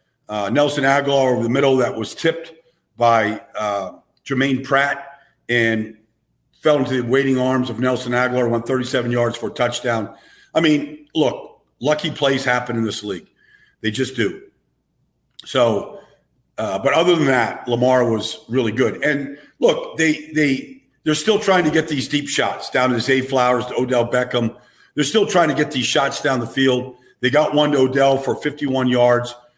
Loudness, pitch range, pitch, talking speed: -18 LUFS, 125-150 Hz, 130 Hz, 175 wpm